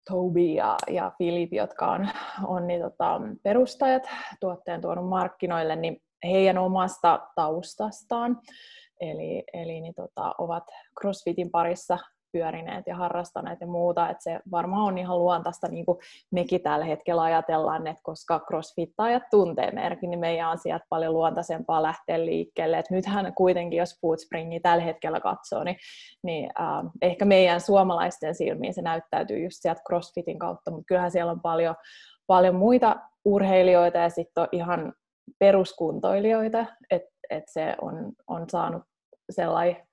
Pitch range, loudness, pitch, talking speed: 165-190 Hz, -26 LUFS, 175 Hz, 140 wpm